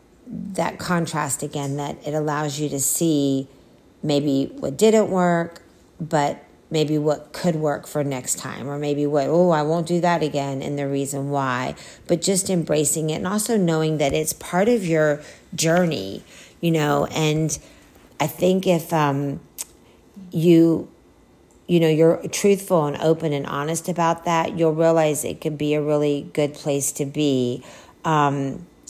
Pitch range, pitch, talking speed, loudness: 145-170 Hz, 155 Hz, 160 wpm, -21 LUFS